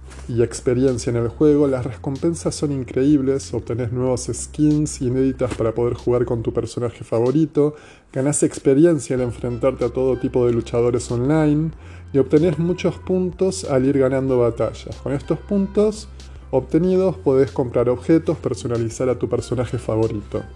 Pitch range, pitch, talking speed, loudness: 120-150 Hz, 130 Hz, 145 wpm, -20 LUFS